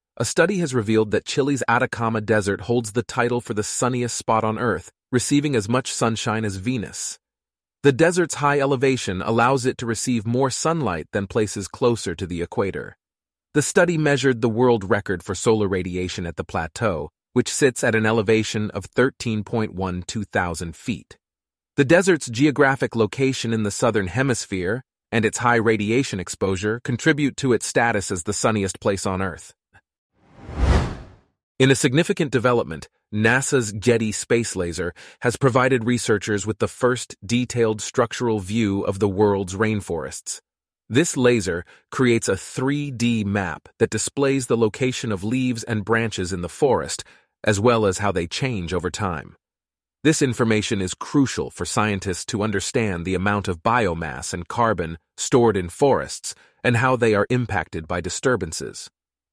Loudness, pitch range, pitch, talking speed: -22 LUFS, 100-125 Hz, 115 Hz, 155 wpm